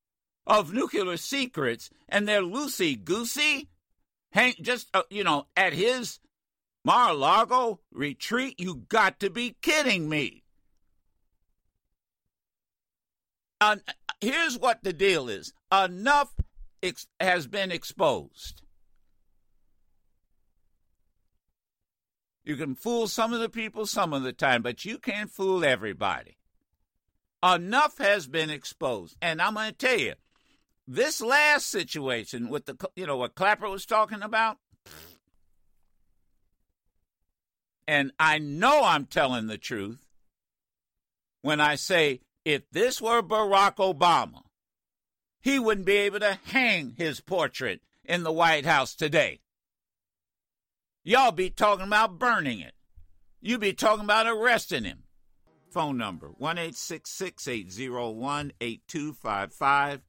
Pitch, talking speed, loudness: 170 Hz, 125 wpm, -26 LUFS